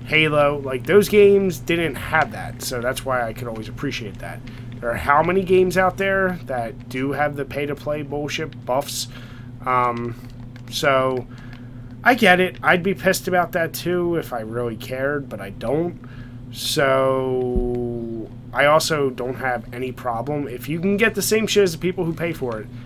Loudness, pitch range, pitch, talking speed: -21 LUFS, 120-165 Hz, 130 Hz, 185 wpm